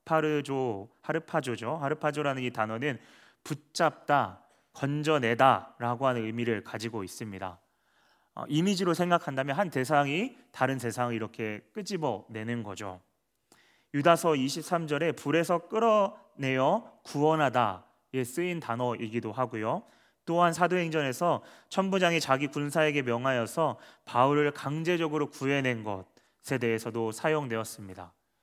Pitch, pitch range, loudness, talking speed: 135 Hz, 115-160 Hz, -29 LUFS, 295 characters per minute